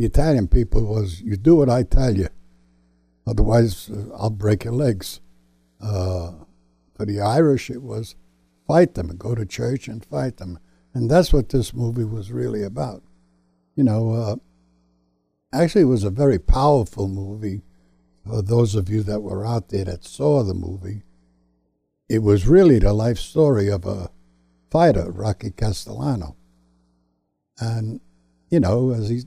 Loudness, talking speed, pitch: -21 LUFS, 155 wpm, 100 Hz